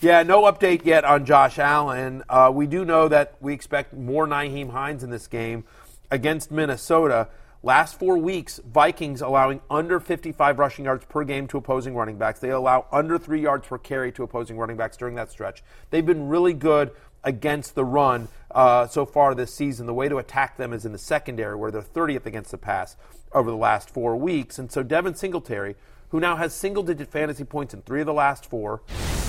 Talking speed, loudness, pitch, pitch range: 205 wpm, -22 LUFS, 140 Hz, 125-155 Hz